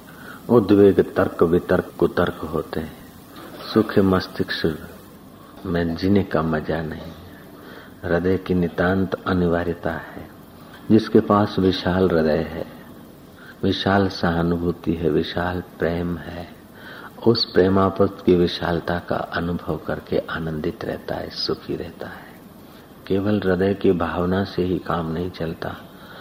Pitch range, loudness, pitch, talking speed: 85-95 Hz, -21 LUFS, 90 Hz, 115 wpm